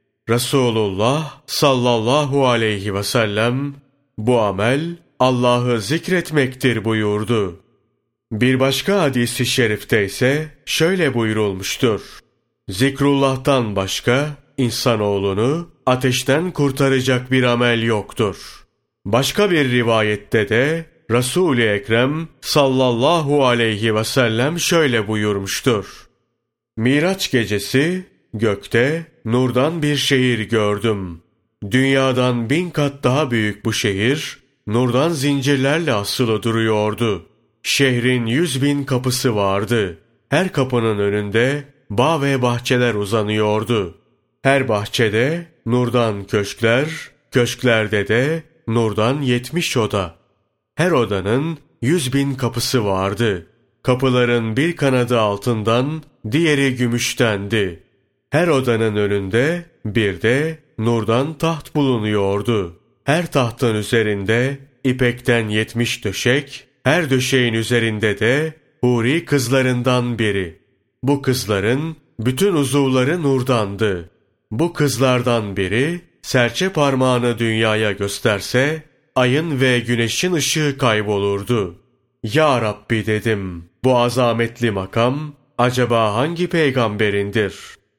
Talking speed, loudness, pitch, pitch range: 90 wpm, -18 LUFS, 125 Hz, 110-140 Hz